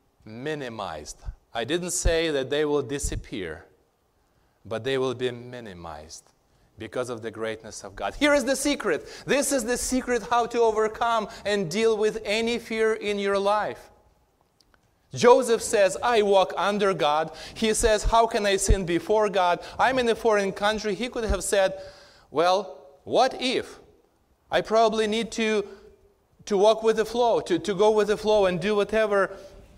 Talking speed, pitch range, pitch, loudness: 165 wpm, 160-225 Hz, 205 Hz, -24 LUFS